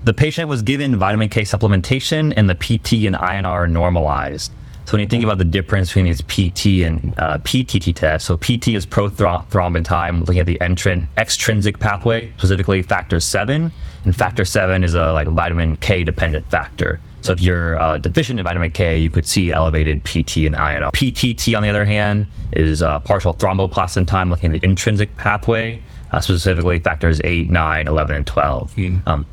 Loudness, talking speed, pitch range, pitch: -17 LUFS, 185 wpm, 85-110 Hz, 95 Hz